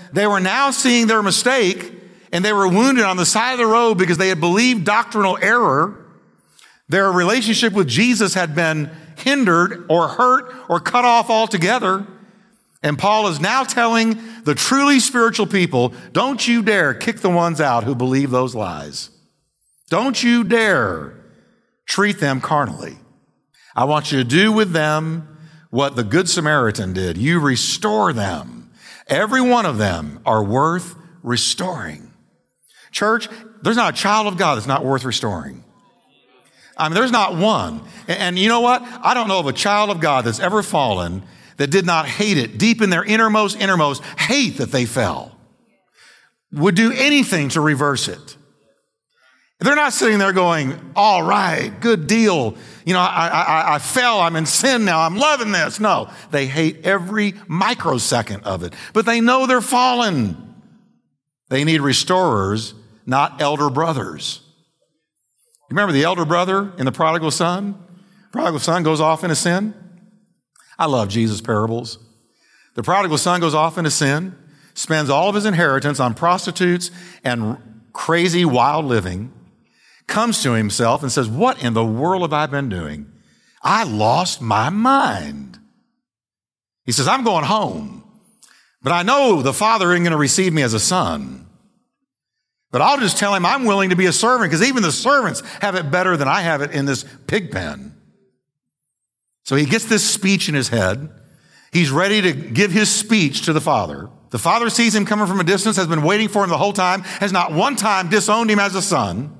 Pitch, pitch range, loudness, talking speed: 180 Hz, 140-215 Hz, -17 LUFS, 170 wpm